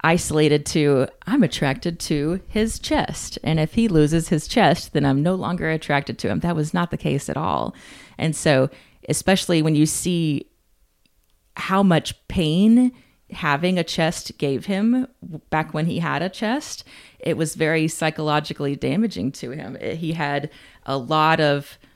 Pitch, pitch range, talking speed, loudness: 160 Hz, 145-180 Hz, 160 wpm, -21 LUFS